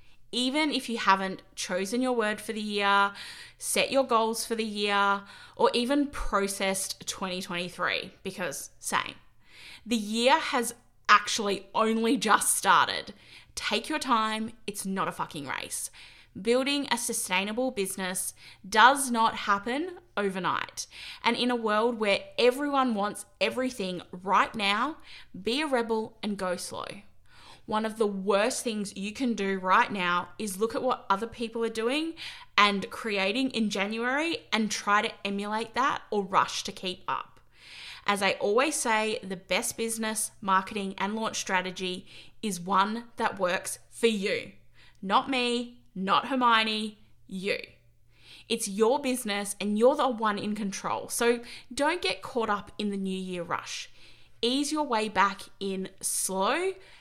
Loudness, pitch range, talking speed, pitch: -28 LUFS, 195-240 Hz, 145 wpm, 215 Hz